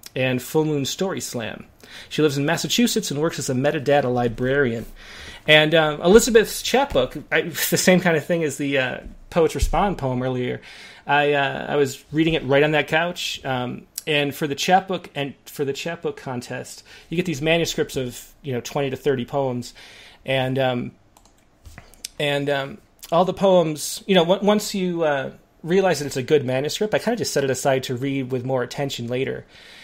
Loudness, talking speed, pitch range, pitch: -21 LUFS, 190 wpm, 130-170 Hz, 145 Hz